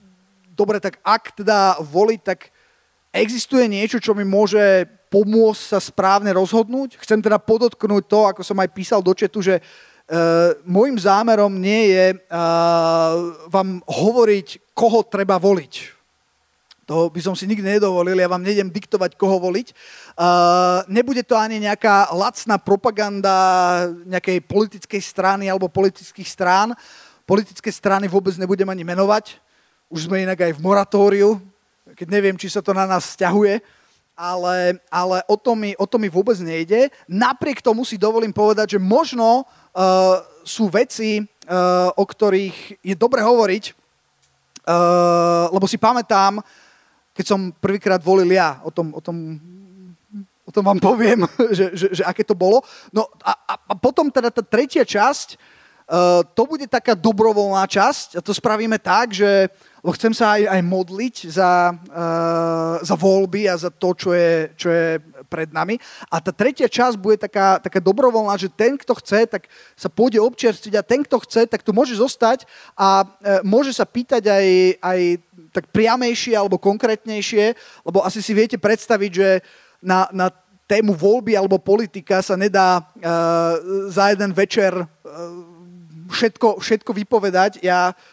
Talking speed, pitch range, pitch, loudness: 155 wpm, 185-215 Hz, 195 Hz, -18 LUFS